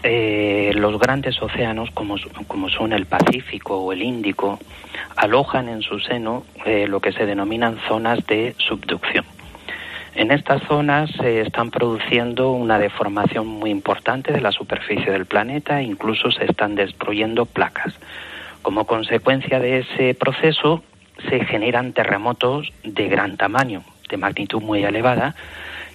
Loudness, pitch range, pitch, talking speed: -20 LUFS, 105-130 Hz, 115 Hz, 140 wpm